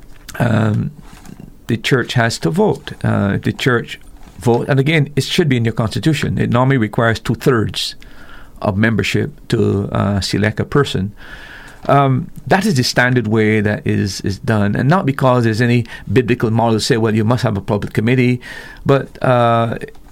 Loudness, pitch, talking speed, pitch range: -16 LUFS, 120 Hz, 175 wpm, 105-135 Hz